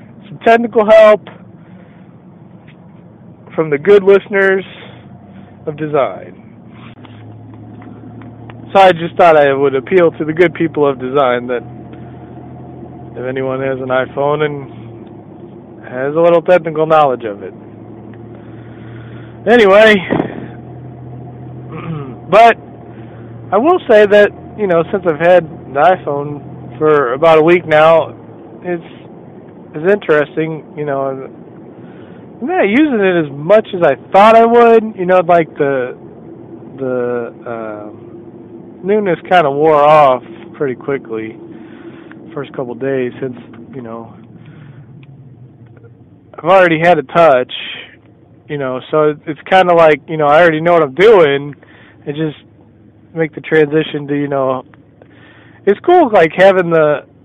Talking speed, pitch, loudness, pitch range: 130 wpm, 150 Hz, -11 LUFS, 120-175 Hz